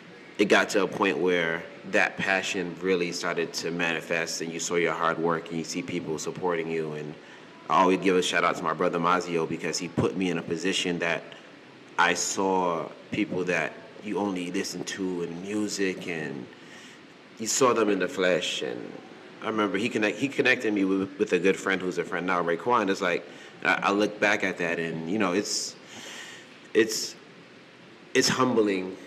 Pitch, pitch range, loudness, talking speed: 90 Hz, 85-95 Hz, -26 LUFS, 190 wpm